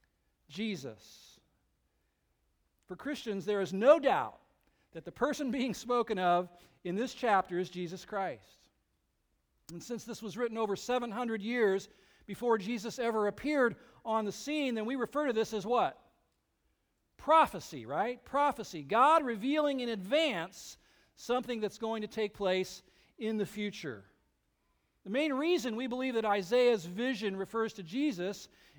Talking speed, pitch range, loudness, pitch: 140 wpm, 185-245 Hz, -33 LUFS, 220 Hz